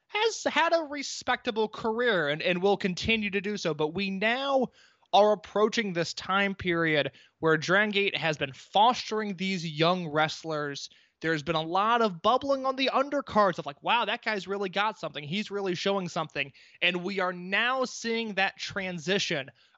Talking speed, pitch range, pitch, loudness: 170 wpm, 170-225 Hz, 195 Hz, -28 LUFS